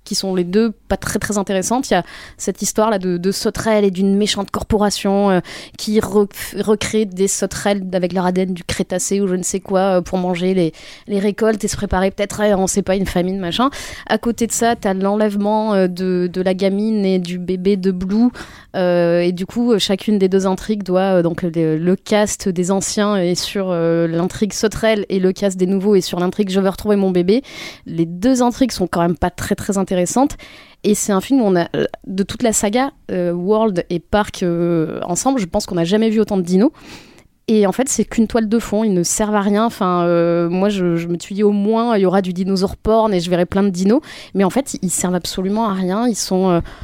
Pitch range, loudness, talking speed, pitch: 185-215 Hz, -17 LUFS, 235 wpm, 195 Hz